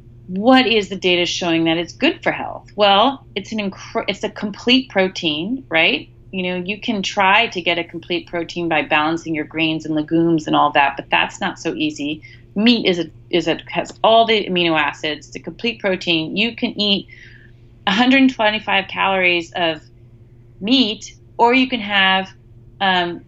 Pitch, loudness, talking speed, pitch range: 175 Hz, -17 LUFS, 180 wpm, 155-205 Hz